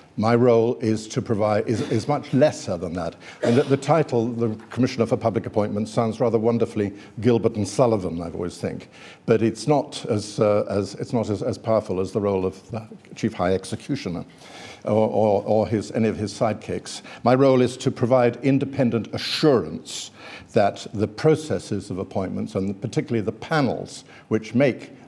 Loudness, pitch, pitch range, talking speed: -23 LUFS, 115 Hz, 105-125 Hz, 175 wpm